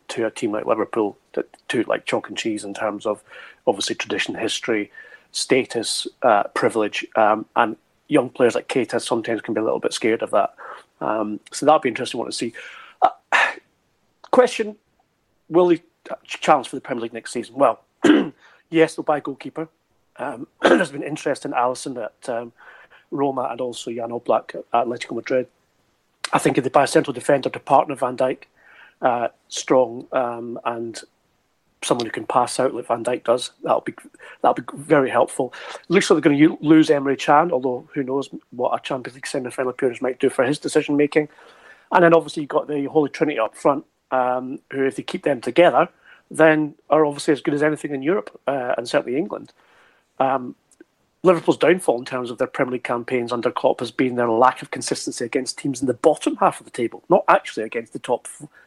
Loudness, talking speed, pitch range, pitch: -21 LUFS, 200 wpm, 125-160 Hz, 145 Hz